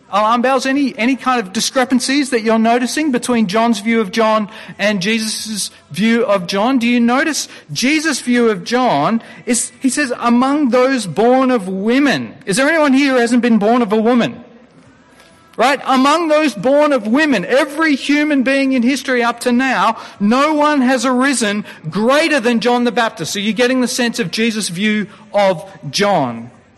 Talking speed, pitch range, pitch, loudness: 180 wpm, 220-265 Hz, 240 Hz, -14 LUFS